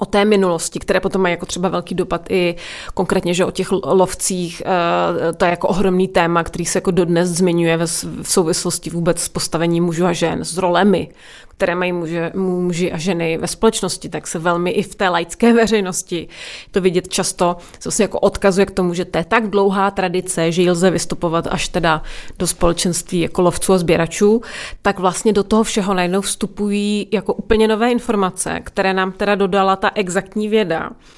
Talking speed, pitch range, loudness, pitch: 185 wpm, 175-200 Hz, -17 LUFS, 185 Hz